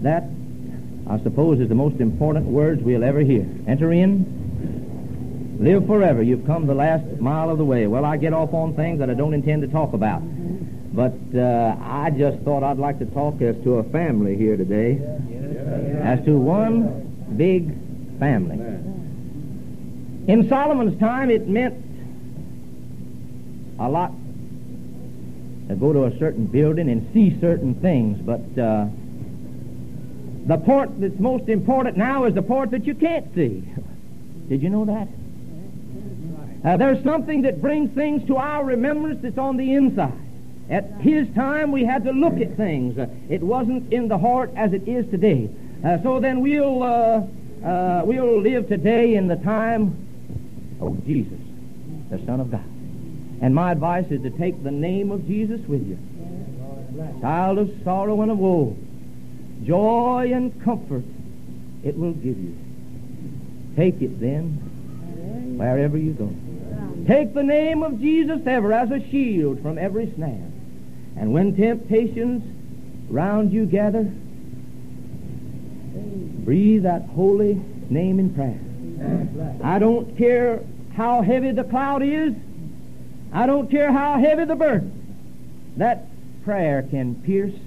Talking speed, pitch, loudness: 150 wpm, 170 Hz, -21 LUFS